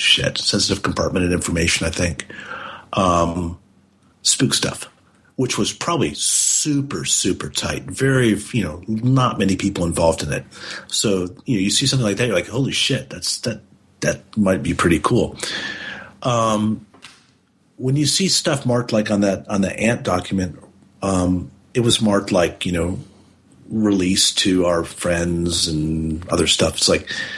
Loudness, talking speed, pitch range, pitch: -19 LUFS, 160 wpm, 85-115 Hz, 95 Hz